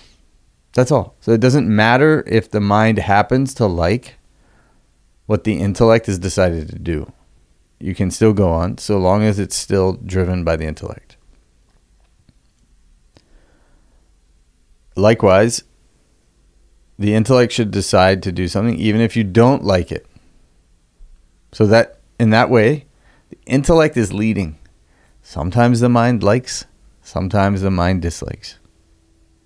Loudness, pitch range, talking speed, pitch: -16 LUFS, 85-115 Hz, 130 wpm, 100 Hz